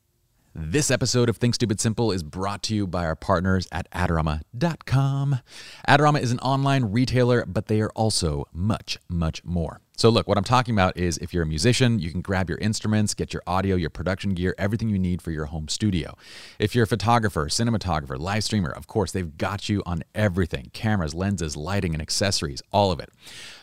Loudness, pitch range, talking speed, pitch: -24 LUFS, 85-115 Hz, 200 wpm, 100 Hz